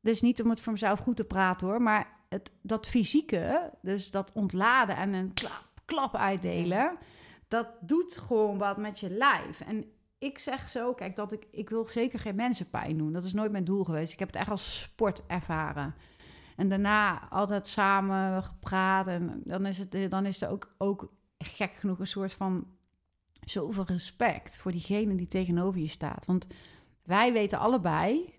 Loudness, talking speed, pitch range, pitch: -30 LUFS, 175 wpm, 185-220 Hz, 195 Hz